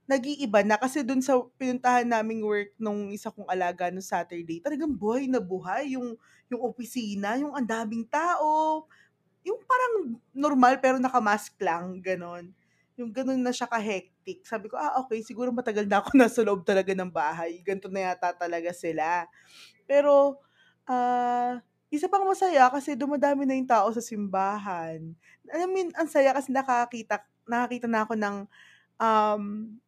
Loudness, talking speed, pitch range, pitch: -27 LUFS, 155 wpm, 200-265 Hz, 235 Hz